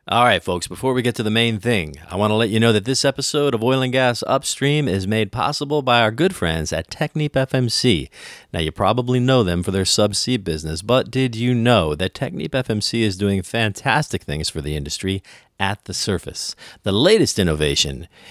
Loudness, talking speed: -19 LUFS, 205 wpm